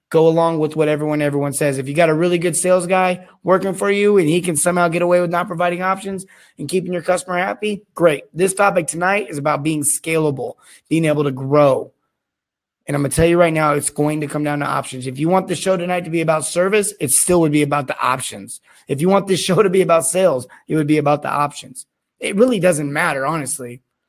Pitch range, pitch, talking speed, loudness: 150-185 Hz, 165 Hz, 240 wpm, -17 LUFS